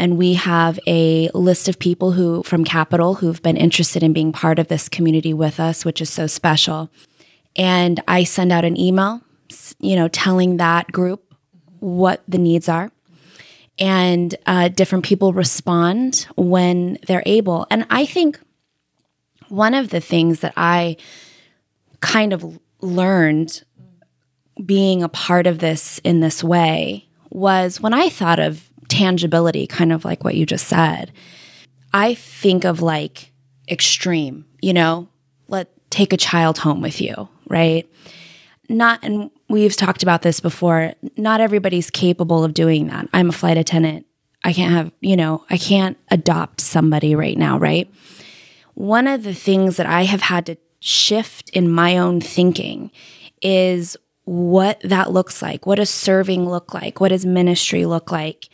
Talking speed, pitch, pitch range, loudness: 160 wpm, 175 Hz, 165-190 Hz, -17 LUFS